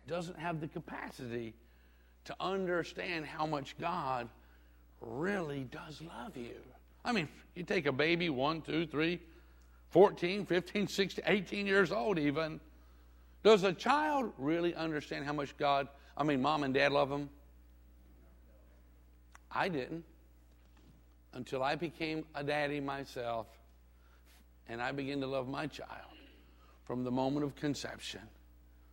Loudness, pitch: -35 LUFS, 140 Hz